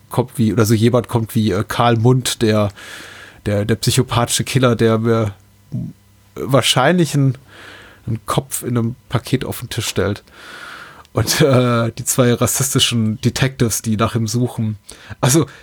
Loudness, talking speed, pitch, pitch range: -17 LUFS, 150 wpm, 115 Hz, 110-125 Hz